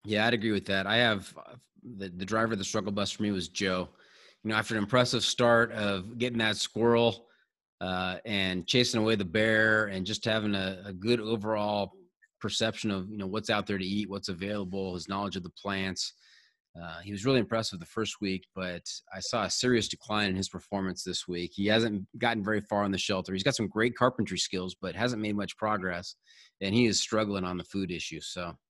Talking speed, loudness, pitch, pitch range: 220 wpm, -30 LUFS, 105 Hz, 95-110 Hz